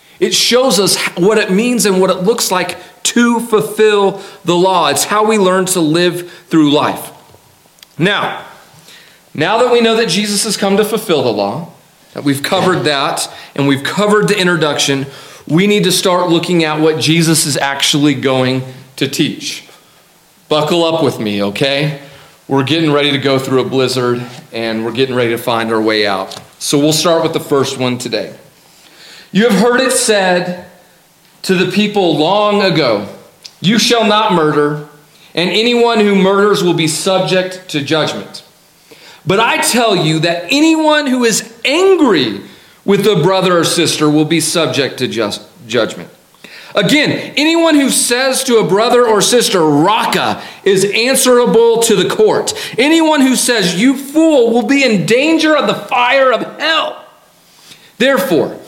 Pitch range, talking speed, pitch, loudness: 150-225 Hz, 165 wpm, 185 Hz, -12 LUFS